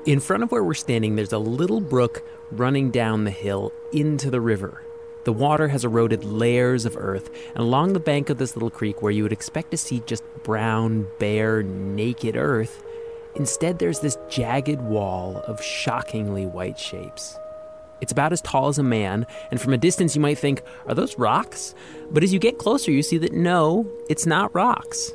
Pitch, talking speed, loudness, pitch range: 140 Hz, 195 wpm, -23 LUFS, 115-175 Hz